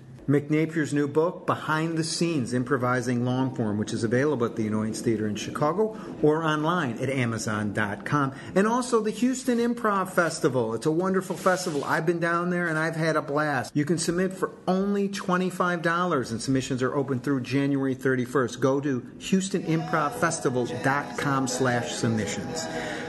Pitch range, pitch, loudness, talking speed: 125-175 Hz, 150 Hz, -26 LUFS, 155 wpm